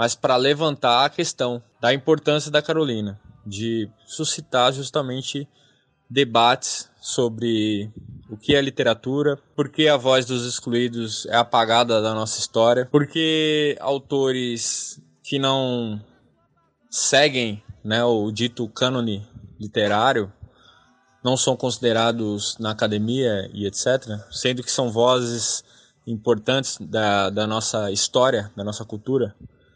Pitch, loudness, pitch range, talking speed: 120 Hz, -21 LUFS, 110-135 Hz, 115 wpm